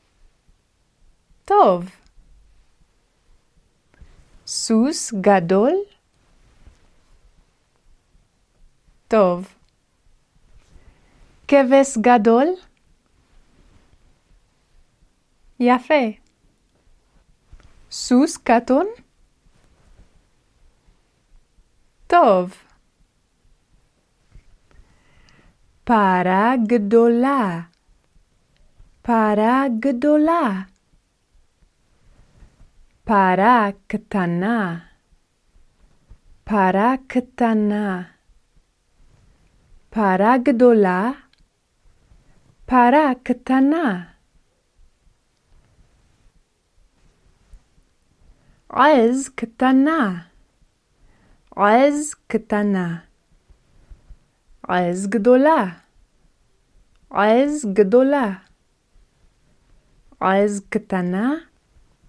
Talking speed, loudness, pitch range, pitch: 30 wpm, -18 LUFS, 200-265 Hz, 230 Hz